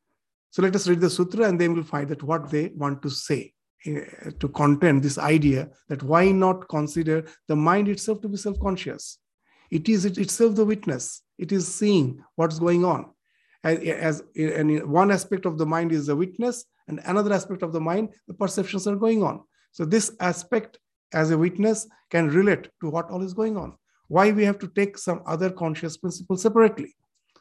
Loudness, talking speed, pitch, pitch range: -24 LUFS, 195 wpm, 180 Hz, 160-200 Hz